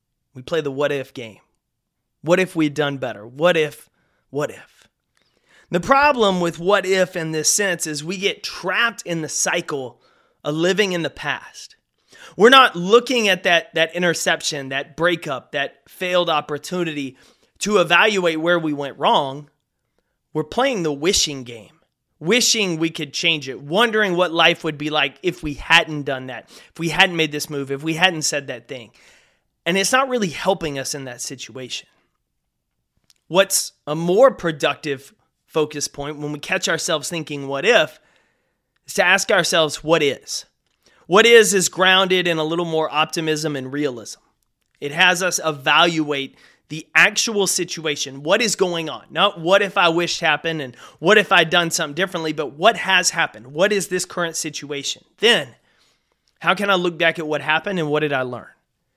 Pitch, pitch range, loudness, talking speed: 165 Hz, 150-185 Hz, -18 LUFS, 175 wpm